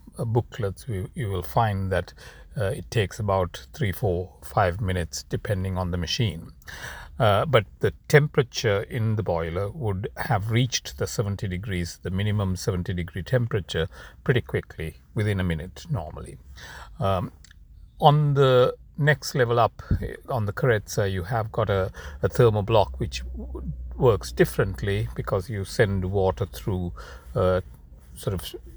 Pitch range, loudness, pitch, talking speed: 90-110 Hz, -25 LUFS, 95 Hz, 140 wpm